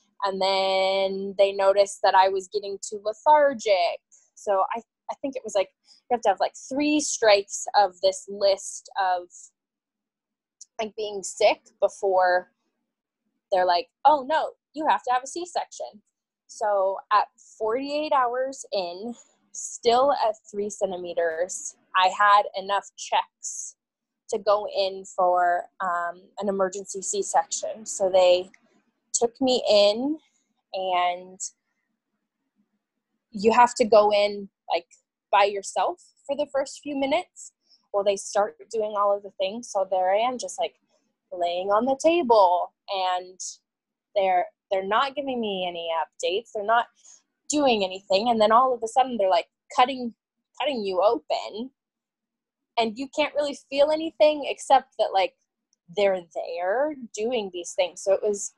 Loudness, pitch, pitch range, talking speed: -24 LUFS, 220 Hz, 195-265 Hz, 145 wpm